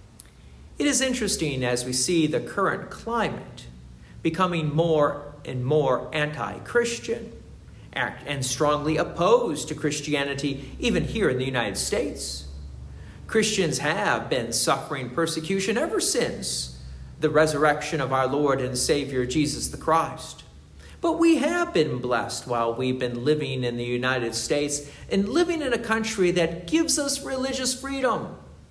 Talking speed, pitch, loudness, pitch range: 140 wpm, 150 Hz, -25 LUFS, 125-195 Hz